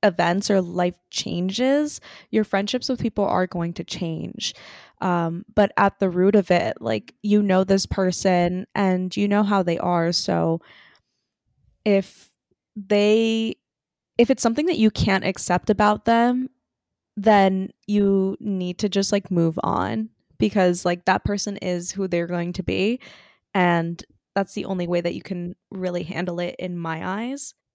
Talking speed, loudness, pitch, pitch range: 160 wpm, -22 LUFS, 190 Hz, 175-210 Hz